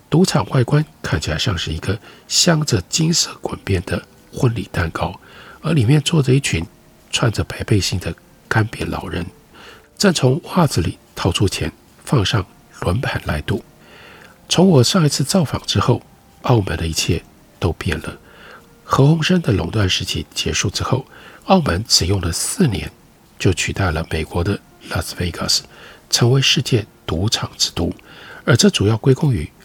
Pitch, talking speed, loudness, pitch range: 120 Hz, 240 characters per minute, -18 LUFS, 95-150 Hz